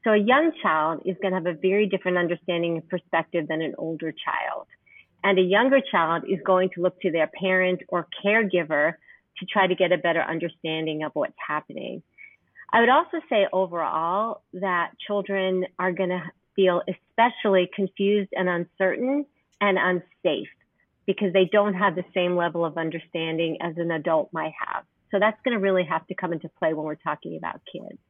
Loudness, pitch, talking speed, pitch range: -24 LUFS, 185 Hz, 185 wpm, 170-200 Hz